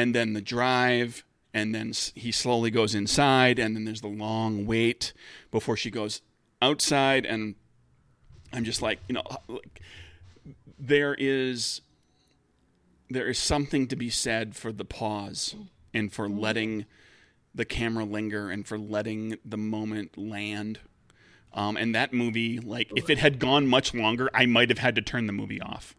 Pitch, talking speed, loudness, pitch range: 110 Hz, 160 wpm, -27 LUFS, 105-125 Hz